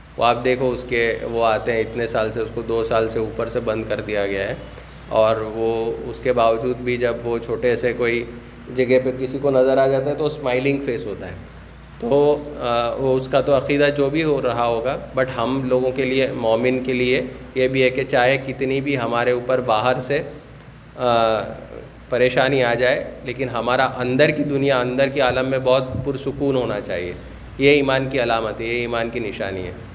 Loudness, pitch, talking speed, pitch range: -20 LUFS, 125 Hz, 205 wpm, 115-135 Hz